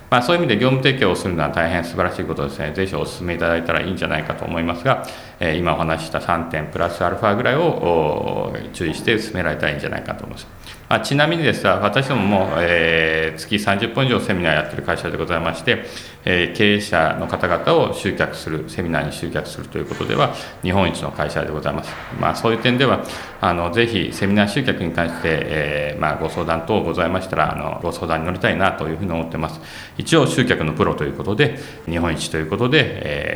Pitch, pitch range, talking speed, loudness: 85 Hz, 80-100 Hz, 465 characters per minute, -19 LUFS